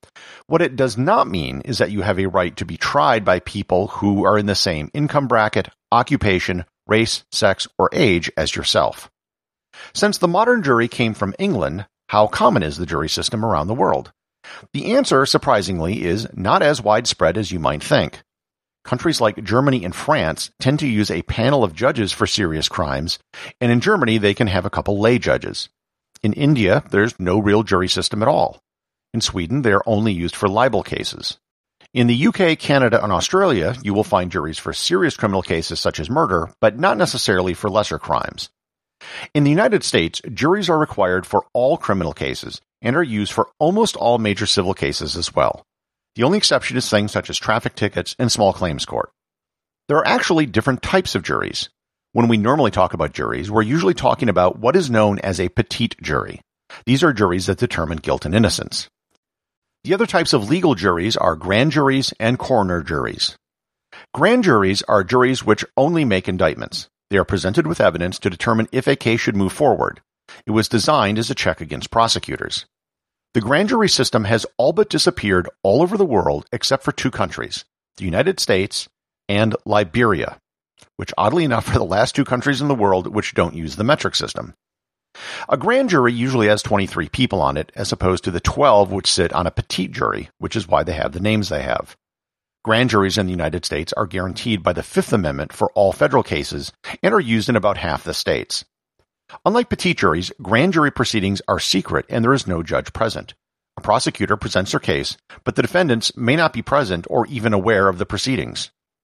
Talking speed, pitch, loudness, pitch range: 195 wpm, 110 Hz, -18 LUFS, 95-130 Hz